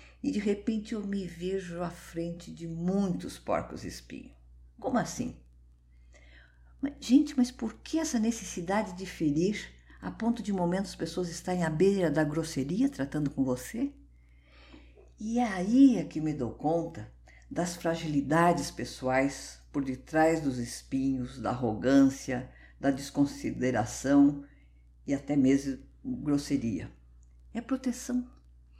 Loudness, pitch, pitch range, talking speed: -30 LUFS, 155 Hz, 130-195 Hz, 130 wpm